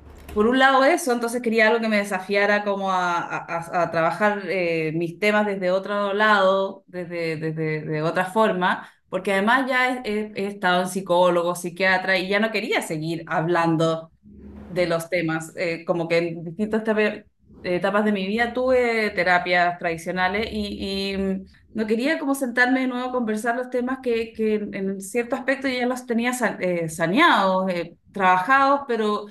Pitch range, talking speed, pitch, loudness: 175-225 Hz, 170 wpm, 200 Hz, -22 LUFS